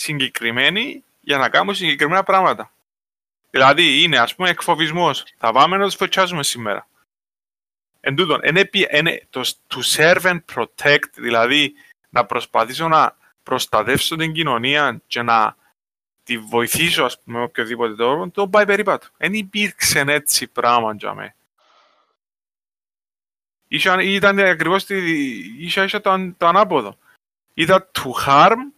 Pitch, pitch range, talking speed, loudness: 170 Hz, 145-195 Hz, 115 wpm, -17 LUFS